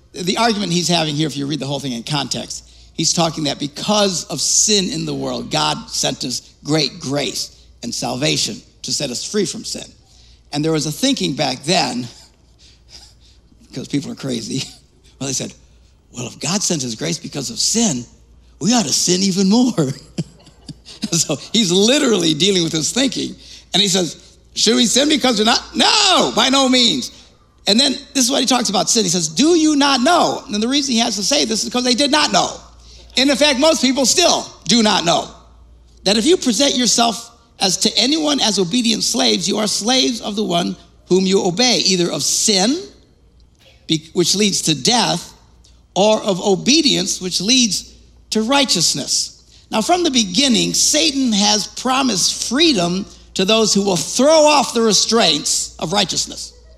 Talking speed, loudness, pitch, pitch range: 185 wpm, -16 LUFS, 210 Hz, 165-250 Hz